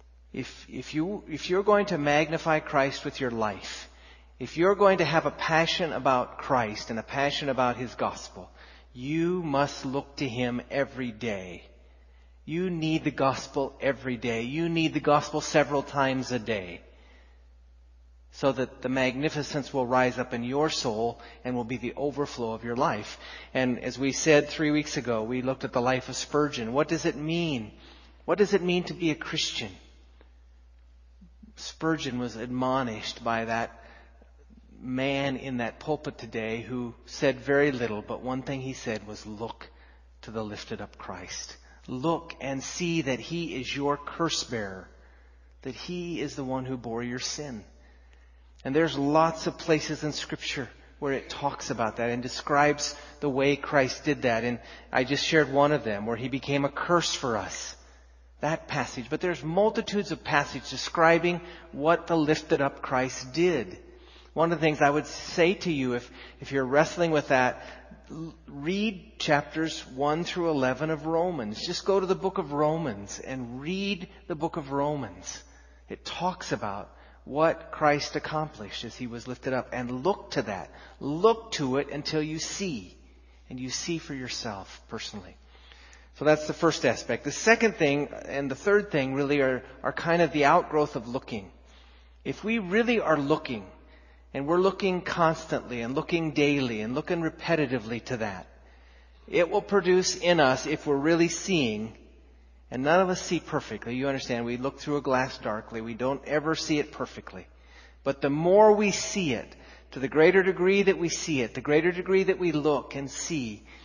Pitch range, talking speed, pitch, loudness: 115-160 Hz, 175 wpm, 140 Hz, -28 LUFS